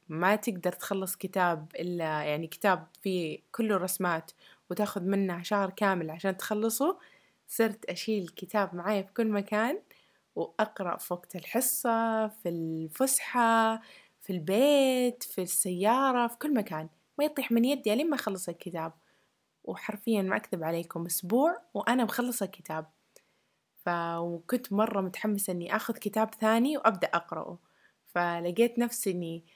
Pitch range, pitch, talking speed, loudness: 175-230 Hz, 200 Hz, 130 wpm, -30 LUFS